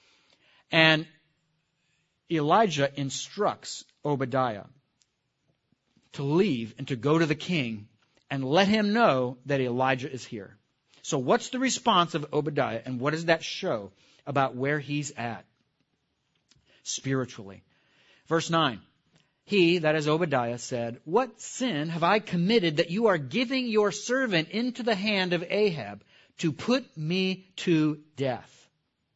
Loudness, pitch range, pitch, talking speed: -27 LUFS, 135-185 Hz, 155 Hz, 130 wpm